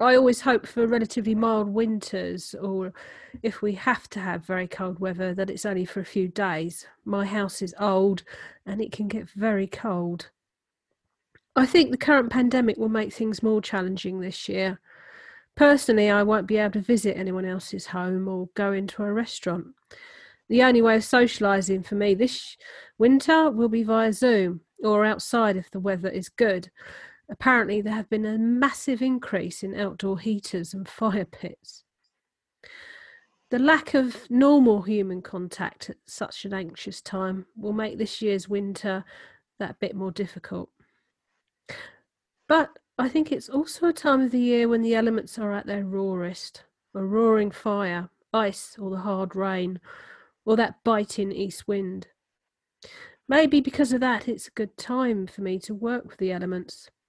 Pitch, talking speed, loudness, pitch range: 210 Hz, 165 wpm, -25 LUFS, 190-240 Hz